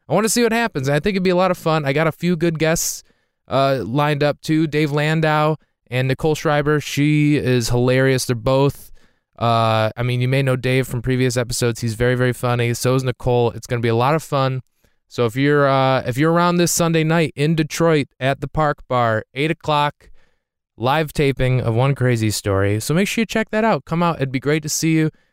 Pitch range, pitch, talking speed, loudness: 125-160 Hz, 140 Hz, 230 wpm, -18 LUFS